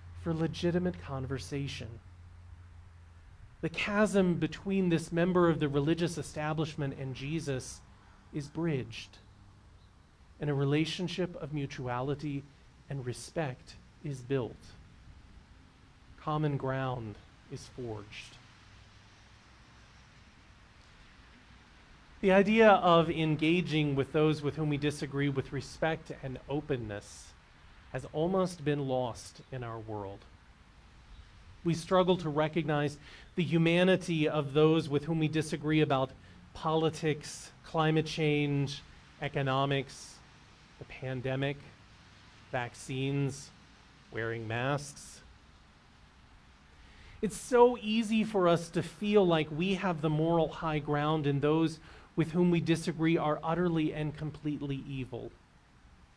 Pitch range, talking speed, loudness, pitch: 115-160 Hz, 105 wpm, -31 LUFS, 145 Hz